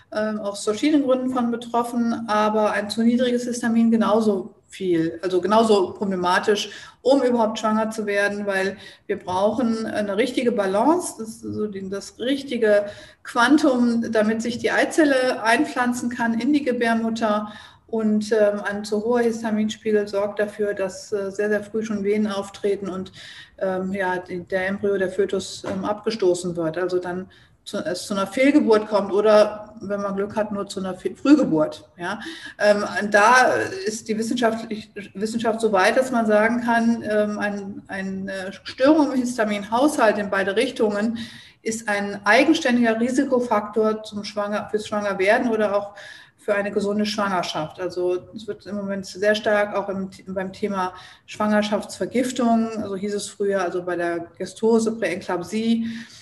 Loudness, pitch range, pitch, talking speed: -22 LUFS, 195-230 Hz, 210 Hz, 145 wpm